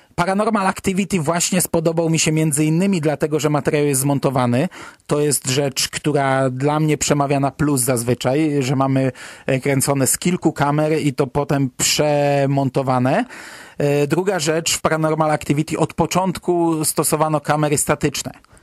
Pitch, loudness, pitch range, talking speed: 150 Hz, -18 LUFS, 140-165 Hz, 140 wpm